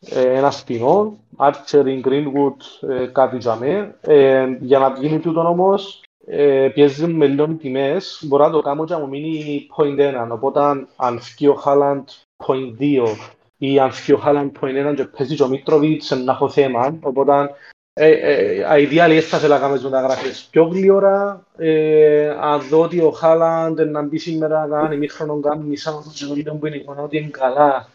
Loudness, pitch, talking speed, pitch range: -17 LUFS, 145 Hz, 150 wpm, 135-155 Hz